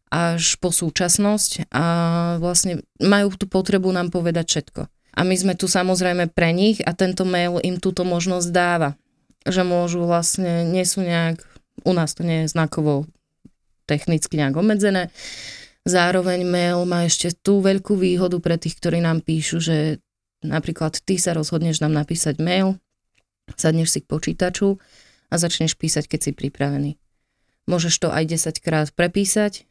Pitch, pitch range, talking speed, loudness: 170 Hz, 155-180 Hz, 155 wpm, -20 LUFS